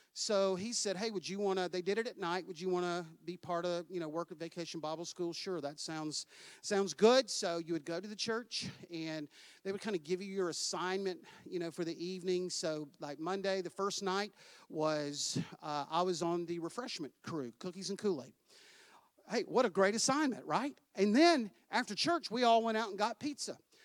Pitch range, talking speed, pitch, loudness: 170-205 Hz, 215 wpm, 185 Hz, -36 LUFS